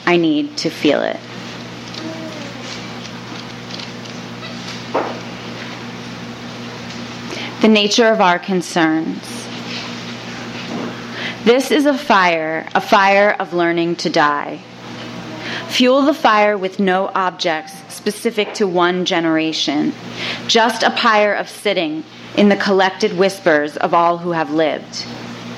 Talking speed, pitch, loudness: 105 wpm, 160 Hz, -16 LUFS